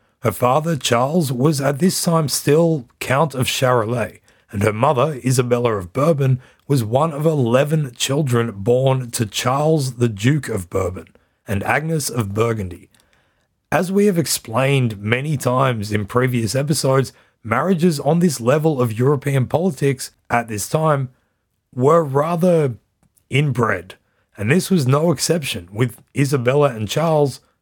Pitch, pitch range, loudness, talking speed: 130 Hz, 115-150 Hz, -18 LUFS, 140 wpm